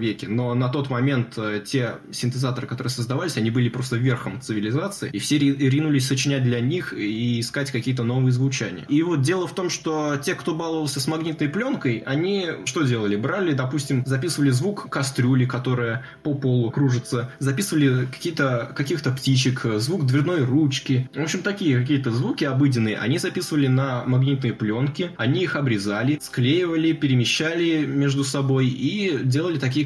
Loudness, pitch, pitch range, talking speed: -23 LUFS, 135 Hz, 125-150 Hz, 155 wpm